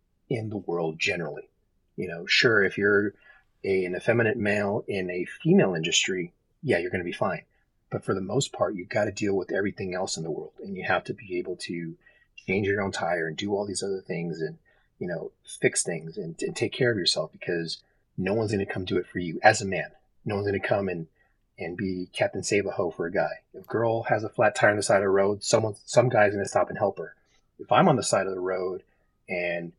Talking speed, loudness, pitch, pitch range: 250 wpm, -26 LUFS, 100 Hz, 90-110 Hz